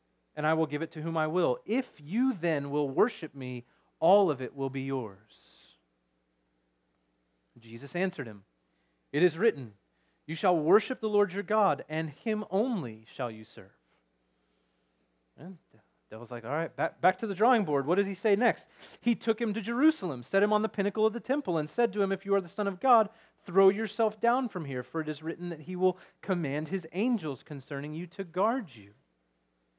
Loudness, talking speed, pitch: -30 LUFS, 205 wpm, 160 Hz